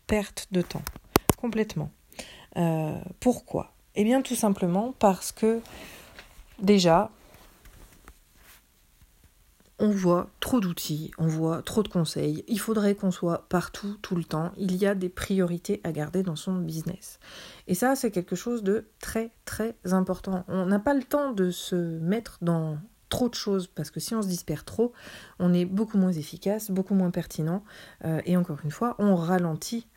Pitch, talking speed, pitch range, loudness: 185 Hz, 170 wpm, 170-215 Hz, -28 LUFS